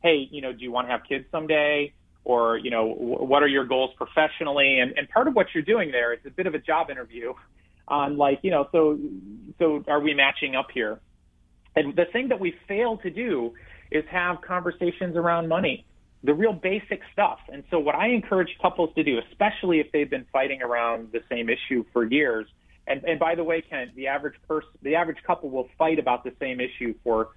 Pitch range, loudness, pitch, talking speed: 125-170 Hz, -25 LUFS, 150 Hz, 220 wpm